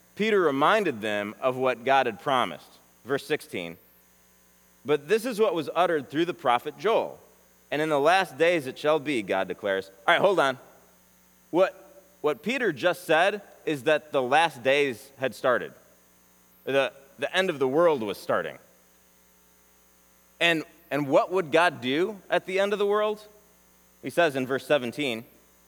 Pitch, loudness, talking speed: 135 Hz, -26 LUFS, 165 wpm